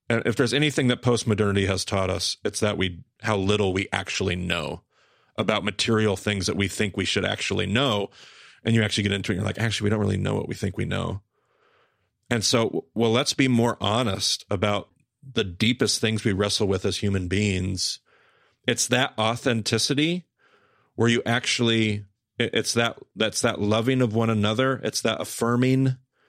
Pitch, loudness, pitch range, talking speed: 110 Hz, -24 LUFS, 100-115 Hz, 185 wpm